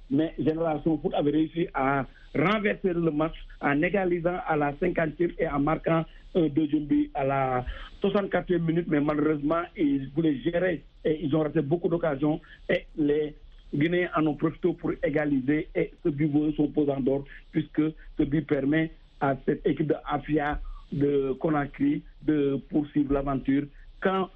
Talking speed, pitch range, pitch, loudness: 160 wpm, 145-165 Hz, 155 Hz, -27 LUFS